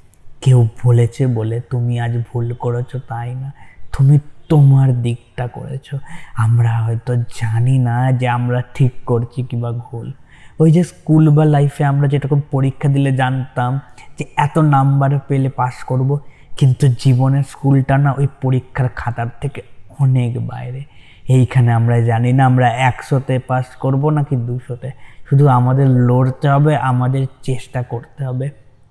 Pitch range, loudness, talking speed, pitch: 120-140 Hz, -16 LUFS, 140 wpm, 130 Hz